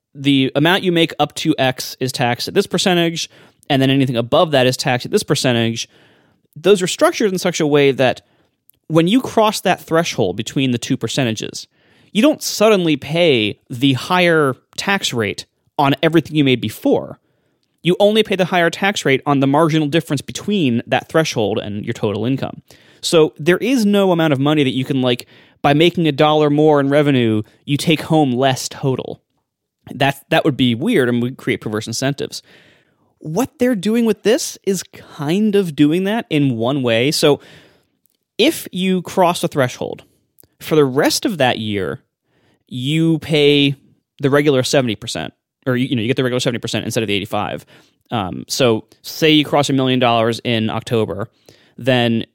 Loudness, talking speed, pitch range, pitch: -16 LUFS, 180 wpm, 125-165 Hz, 145 Hz